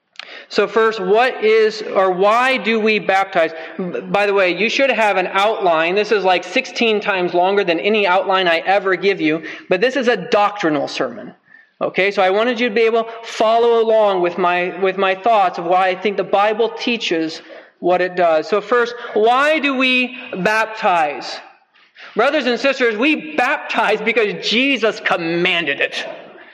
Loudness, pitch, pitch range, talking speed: -16 LUFS, 210 Hz, 185-235 Hz, 175 wpm